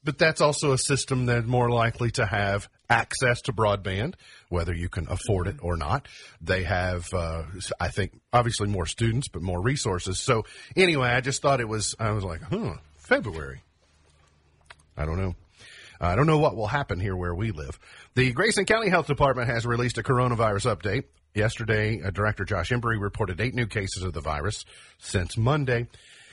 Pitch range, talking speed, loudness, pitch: 90-125 Hz, 180 wpm, -26 LUFS, 110 Hz